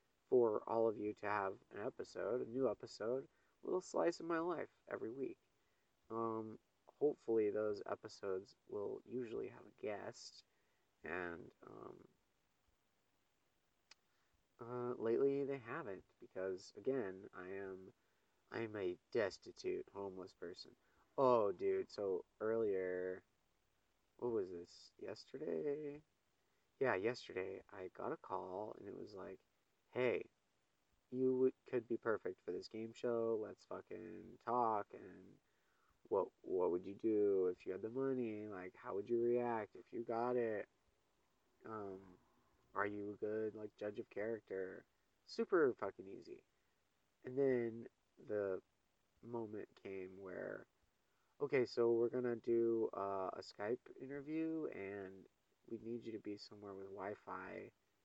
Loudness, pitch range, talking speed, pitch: -43 LUFS, 100-135 Hz, 135 wpm, 115 Hz